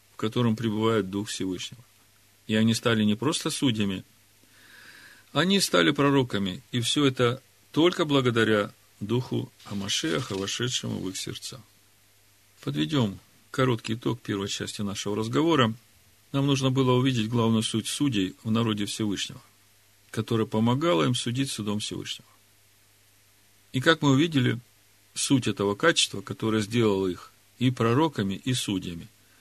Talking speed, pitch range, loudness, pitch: 125 wpm, 100-130 Hz, -26 LUFS, 110 Hz